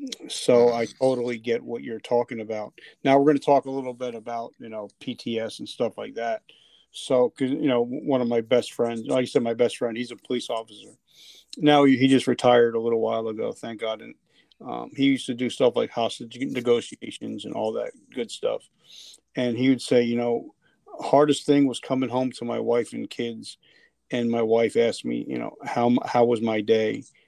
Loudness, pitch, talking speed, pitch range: -24 LUFS, 120 Hz, 210 wpm, 115-130 Hz